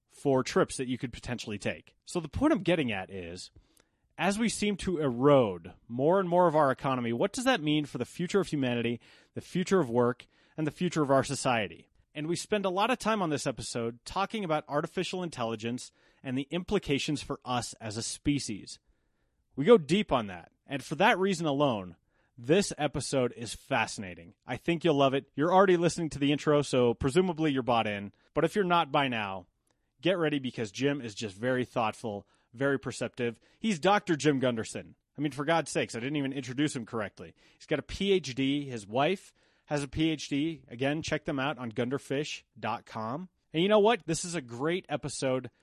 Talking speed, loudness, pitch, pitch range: 200 wpm, -30 LUFS, 140 Hz, 120-170 Hz